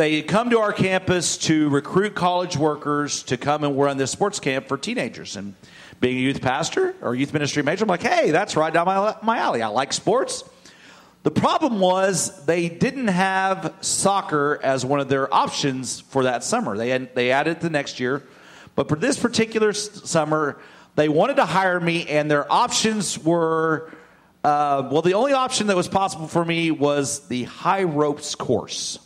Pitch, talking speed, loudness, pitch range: 160 Hz, 185 wpm, -21 LUFS, 145-195 Hz